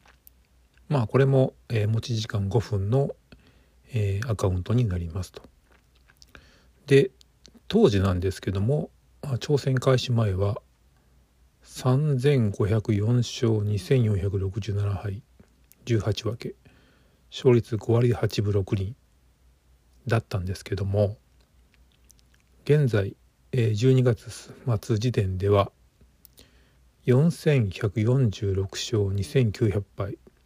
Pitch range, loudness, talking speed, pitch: 95-120 Hz, -25 LUFS, 130 characters per minute, 105 Hz